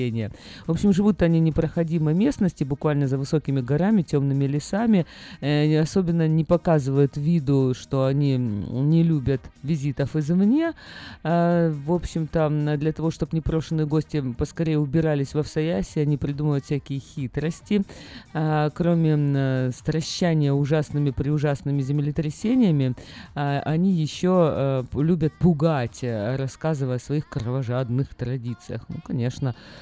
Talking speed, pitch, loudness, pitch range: 110 wpm, 150 Hz, -23 LUFS, 140-165 Hz